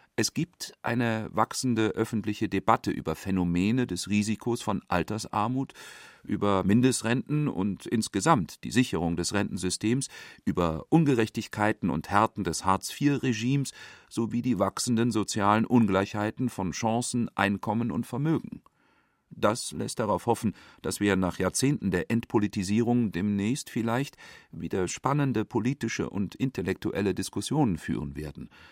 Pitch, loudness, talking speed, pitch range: 110 Hz, -28 LUFS, 115 wpm, 100-120 Hz